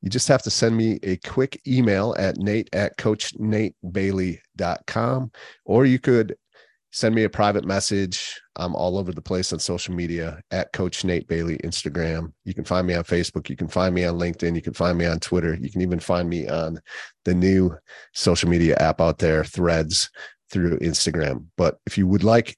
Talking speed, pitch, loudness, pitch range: 195 wpm, 90 Hz, -23 LUFS, 85-105 Hz